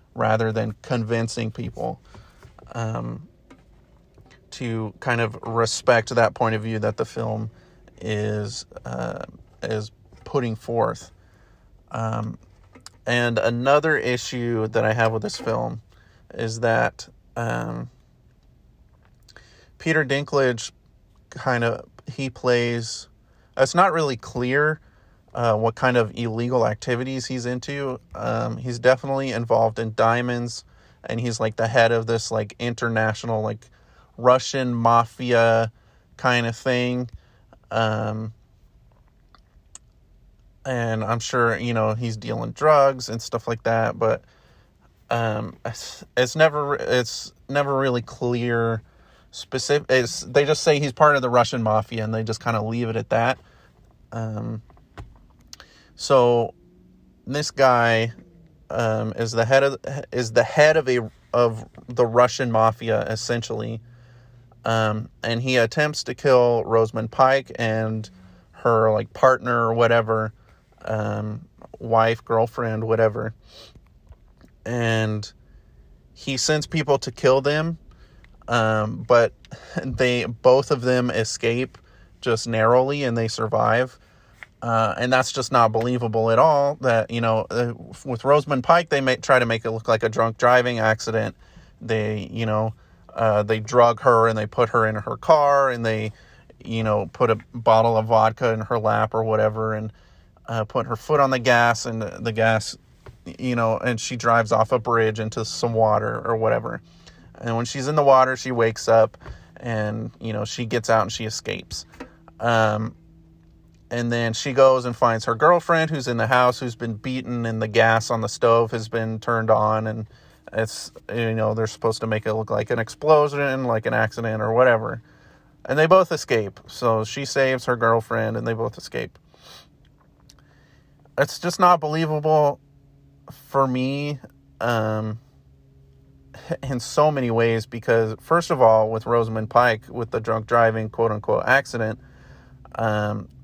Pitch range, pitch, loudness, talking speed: 110-125 Hz, 115 Hz, -22 LUFS, 145 wpm